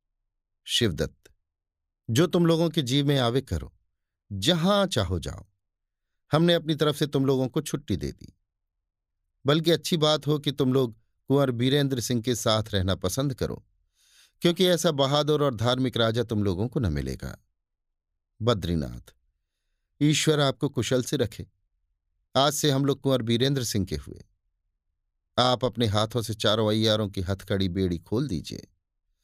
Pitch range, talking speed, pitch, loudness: 90-140 Hz, 150 wpm, 110 Hz, -25 LUFS